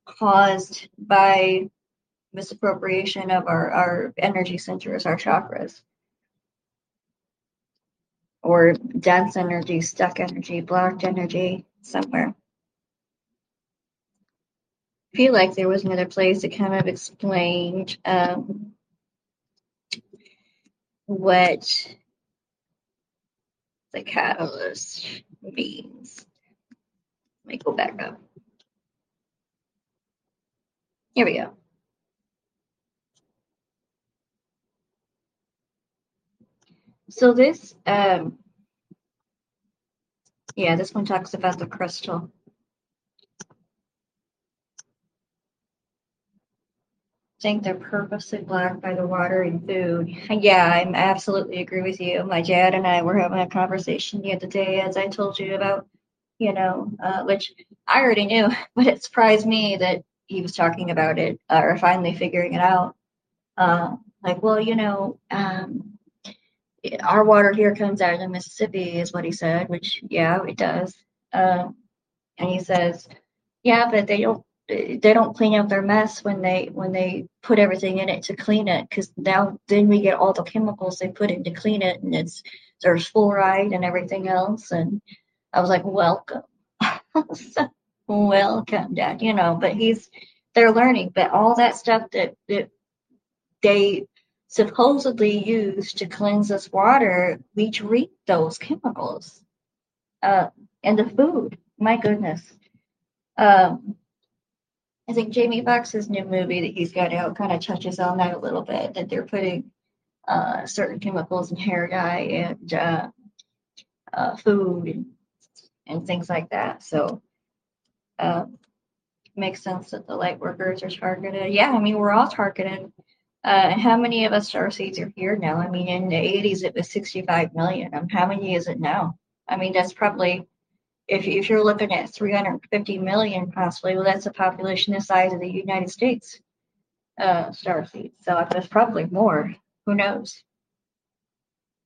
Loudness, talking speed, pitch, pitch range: -21 LUFS, 135 wpm, 195 Hz, 180-210 Hz